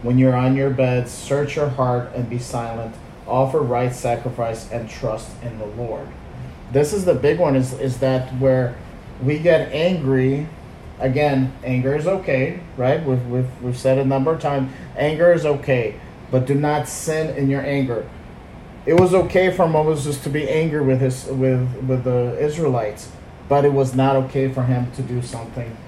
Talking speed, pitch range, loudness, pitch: 185 wpm, 125-145 Hz, -20 LUFS, 130 Hz